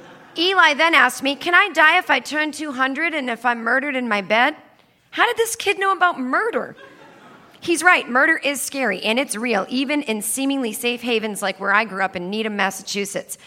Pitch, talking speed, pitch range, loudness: 265 Hz, 205 wpm, 220-320 Hz, -19 LUFS